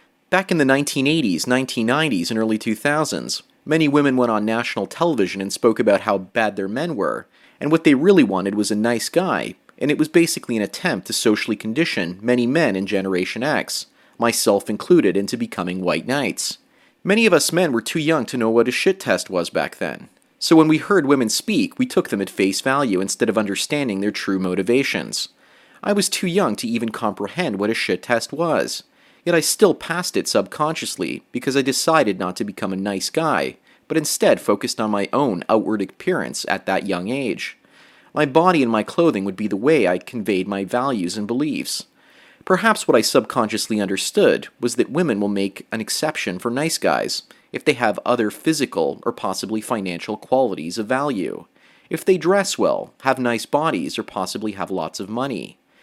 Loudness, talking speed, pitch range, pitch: -20 LUFS, 190 wpm, 100-160 Hz, 120 Hz